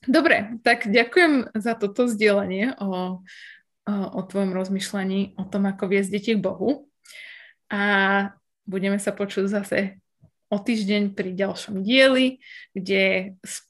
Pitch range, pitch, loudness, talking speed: 195-235 Hz, 205 Hz, -23 LUFS, 130 wpm